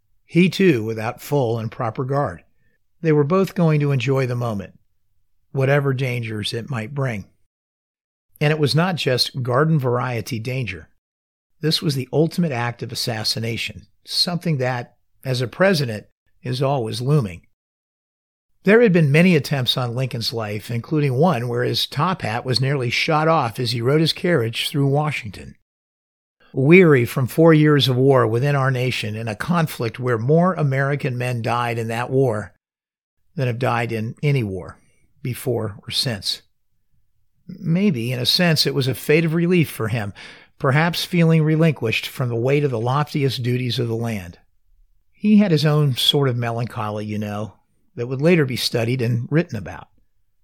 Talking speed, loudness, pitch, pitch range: 165 wpm, -20 LUFS, 125 Hz, 115-150 Hz